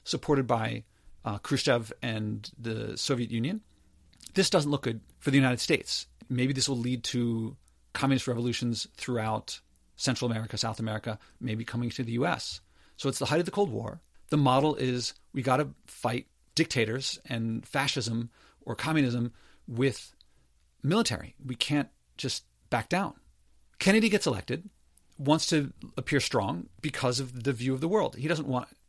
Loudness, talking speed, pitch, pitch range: -30 LUFS, 160 wpm, 125 Hz, 115-140 Hz